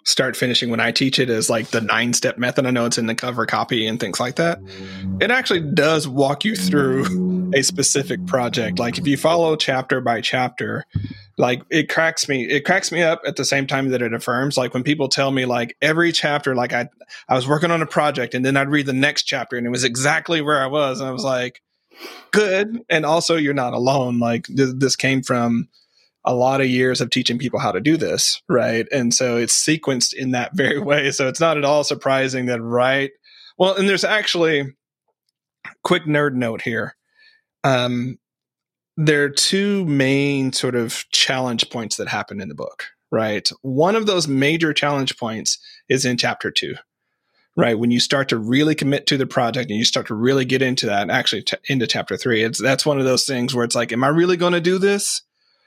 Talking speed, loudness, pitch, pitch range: 215 wpm, -19 LUFS, 135 Hz, 125-150 Hz